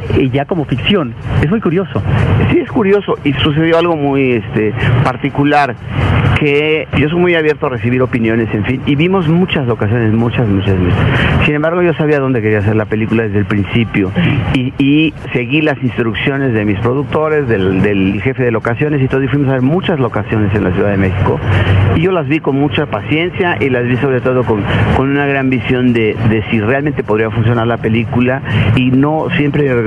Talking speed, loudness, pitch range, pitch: 195 wpm, -13 LUFS, 110-145 Hz, 125 Hz